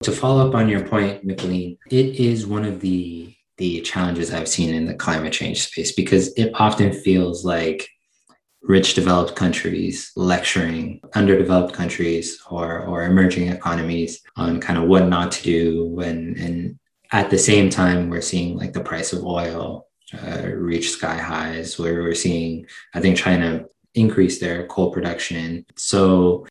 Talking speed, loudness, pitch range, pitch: 160 wpm, -20 LUFS, 85-95 Hz, 90 Hz